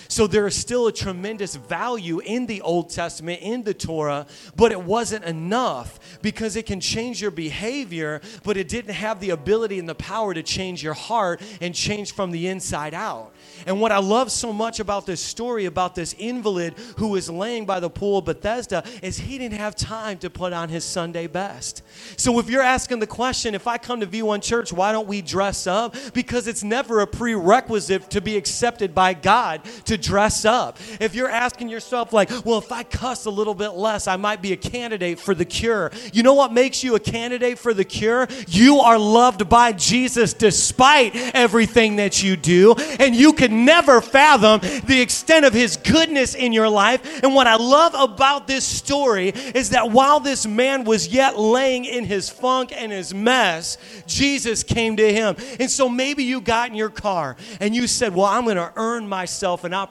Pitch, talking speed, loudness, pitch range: 220 Hz, 205 wpm, -19 LUFS, 195-245 Hz